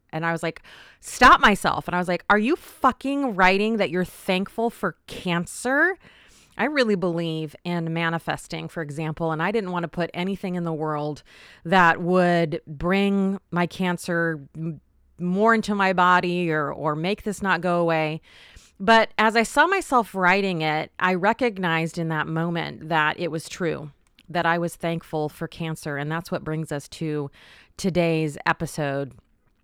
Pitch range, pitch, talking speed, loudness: 160-195 Hz, 170 Hz, 170 wpm, -23 LUFS